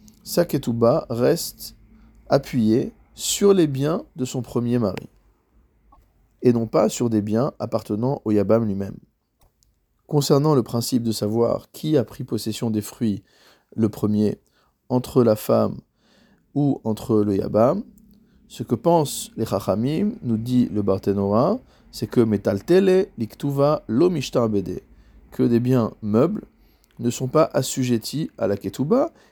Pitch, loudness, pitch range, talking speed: 120 Hz, -22 LUFS, 110-145 Hz, 130 wpm